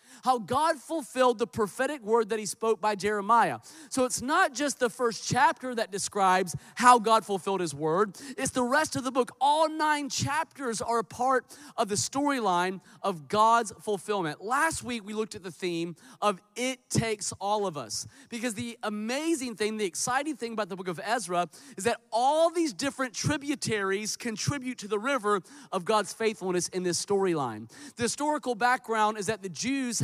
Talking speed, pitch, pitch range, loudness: 180 wpm, 225 Hz, 200-260 Hz, -28 LUFS